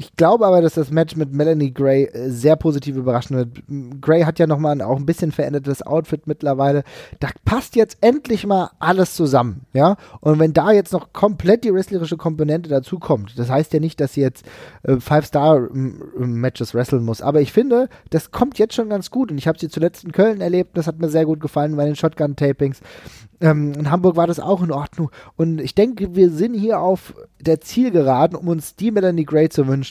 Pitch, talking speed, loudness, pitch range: 155 Hz, 215 wpm, -18 LUFS, 140-180 Hz